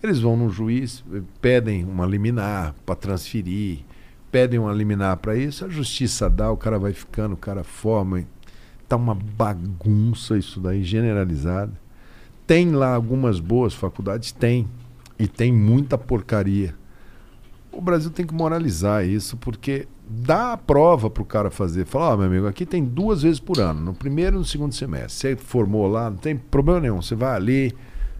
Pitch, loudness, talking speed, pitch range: 115 Hz, -22 LUFS, 170 wpm, 100-130 Hz